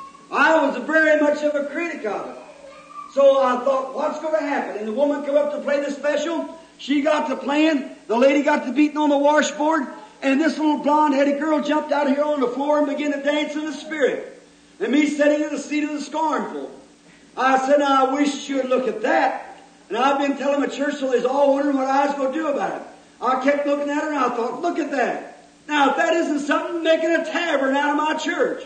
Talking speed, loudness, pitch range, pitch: 245 wpm, -20 LUFS, 275-305 Hz, 290 Hz